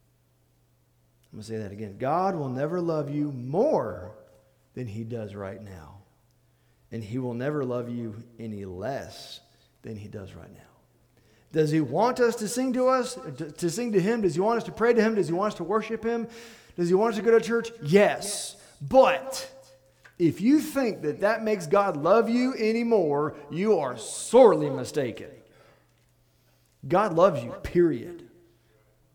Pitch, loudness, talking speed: 150 Hz, -25 LUFS, 175 wpm